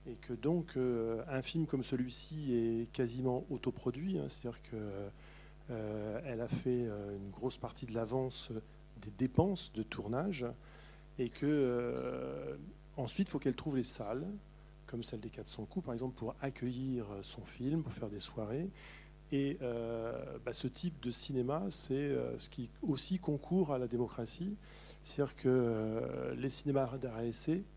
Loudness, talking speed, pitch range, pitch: -38 LUFS, 150 wpm, 115-150 Hz, 130 Hz